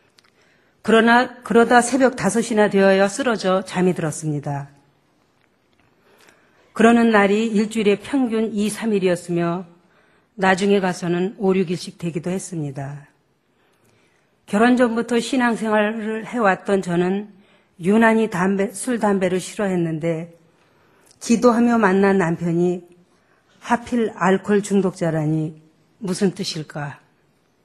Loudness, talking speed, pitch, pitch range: -19 LUFS, 230 characters per minute, 195 Hz, 175-220 Hz